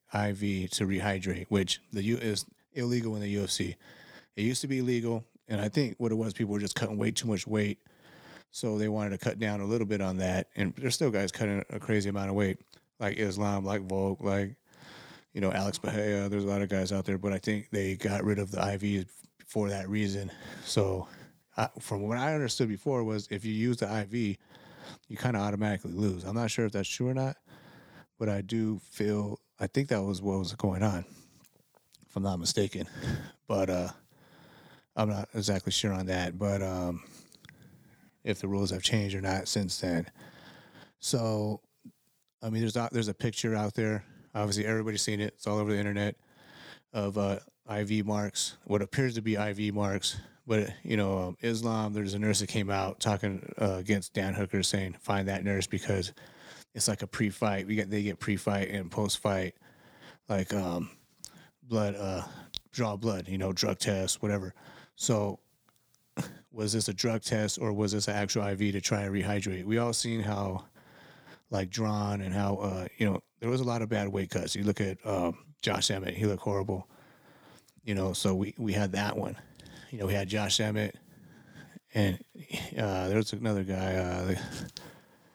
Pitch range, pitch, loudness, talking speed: 95-110 Hz, 105 Hz, -32 LUFS, 195 wpm